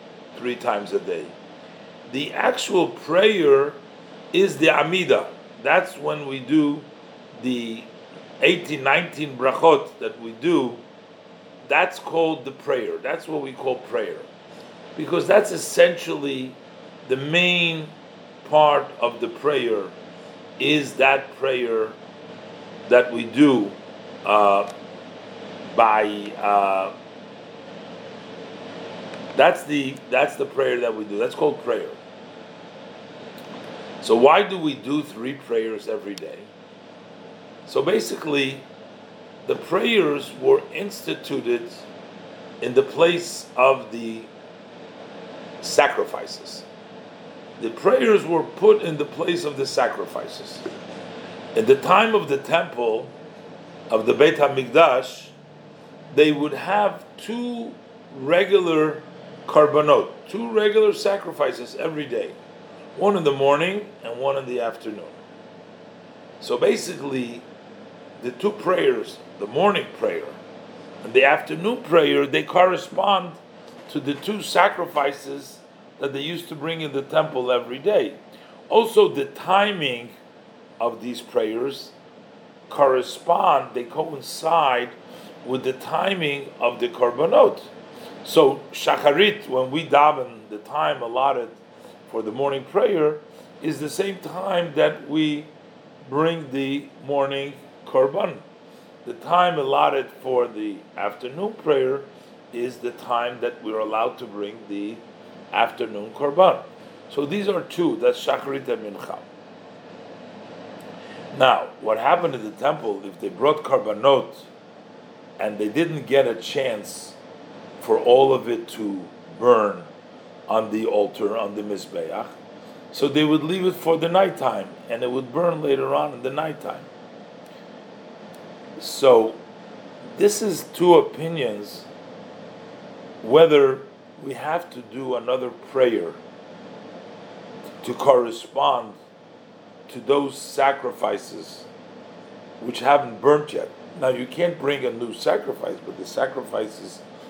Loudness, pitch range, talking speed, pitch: -21 LUFS, 130-205 Hz, 120 wpm, 150 Hz